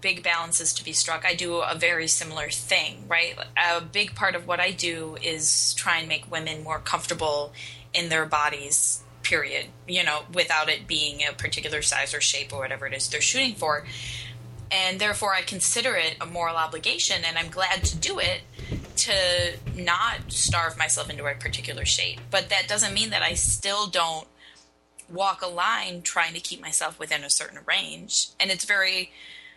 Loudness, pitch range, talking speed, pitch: -24 LUFS, 140-175 Hz, 185 wpm, 160 Hz